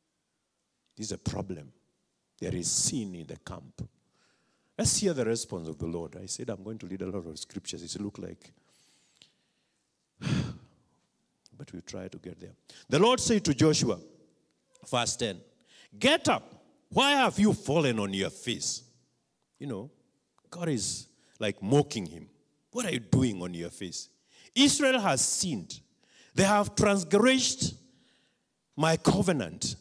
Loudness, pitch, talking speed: -28 LUFS, 130 Hz, 150 wpm